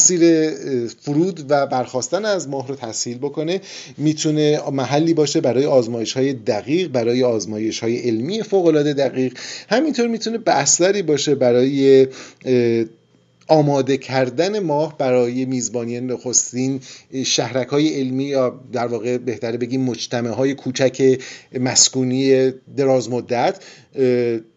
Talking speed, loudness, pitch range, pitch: 115 wpm, -18 LUFS, 125-150 Hz, 130 Hz